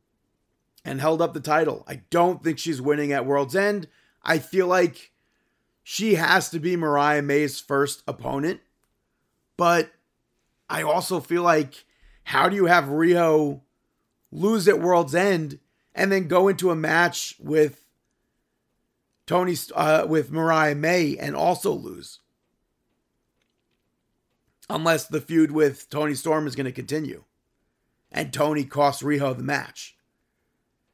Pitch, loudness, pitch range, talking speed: 160 Hz, -23 LUFS, 150-175 Hz, 135 wpm